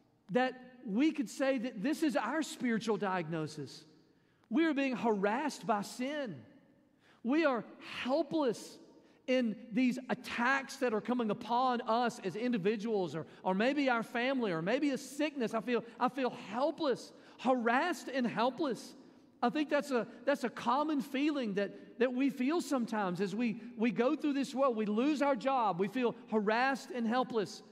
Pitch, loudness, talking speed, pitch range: 245 Hz, -34 LUFS, 160 wpm, 220-275 Hz